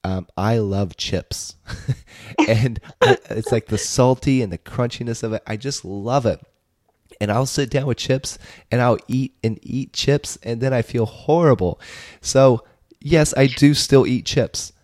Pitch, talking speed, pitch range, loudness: 120 Hz, 170 wpm, 105-130 Hz, -20 LUFS